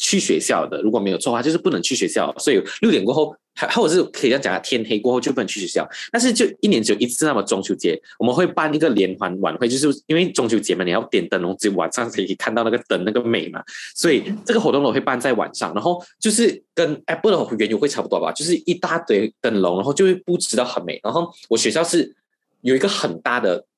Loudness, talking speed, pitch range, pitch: -20 LUFS, 390 characters per minute, 120-180 Hz, 150 Hz